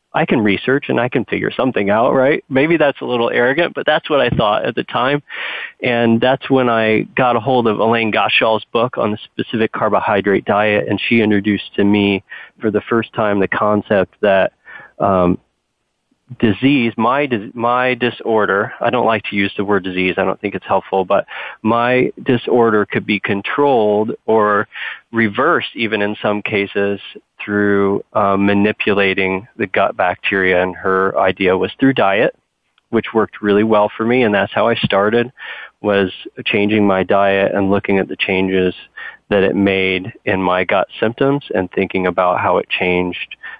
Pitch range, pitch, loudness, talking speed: 95-115 Hz, 105 Hz, -16 LUFS, 175 wpm